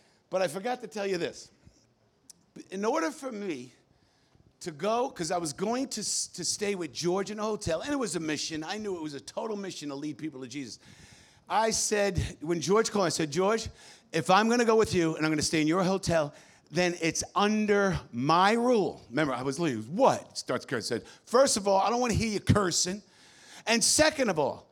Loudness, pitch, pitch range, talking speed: -28 LUFS, 185 Hz, 160-215 Hz, 220 wpm